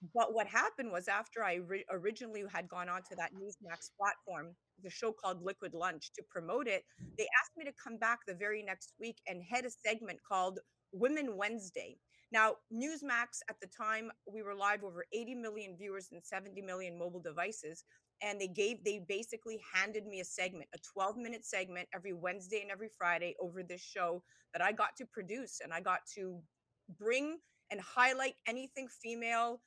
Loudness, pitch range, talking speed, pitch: -39 LUFS, 185-230 Hz, 185 wpm, 205 Hz